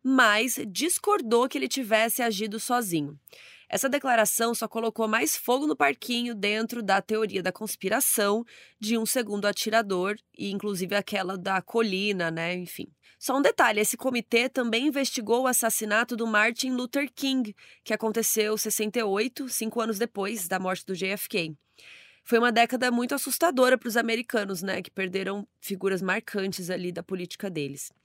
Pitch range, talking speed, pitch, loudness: 195-245 Hz, 150 wpm, 220 Hz, -26 LUFS